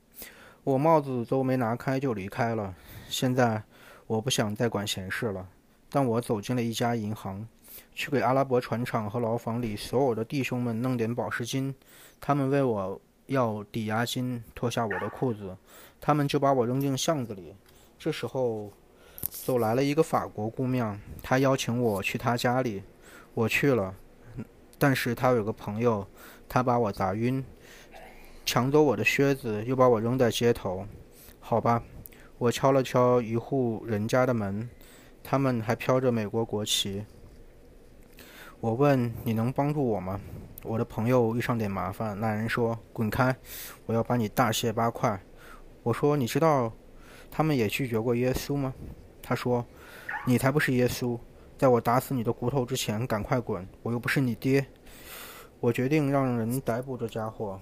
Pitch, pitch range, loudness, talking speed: 120 Hz, 110-130 Hz, -28 LUFS, 235 characters per minute